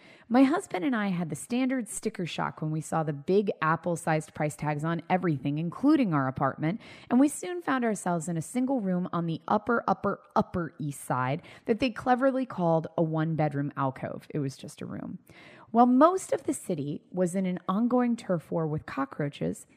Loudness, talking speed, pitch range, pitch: -28 LUFS, 195 wpm, 155-240 Hz, 175 Hz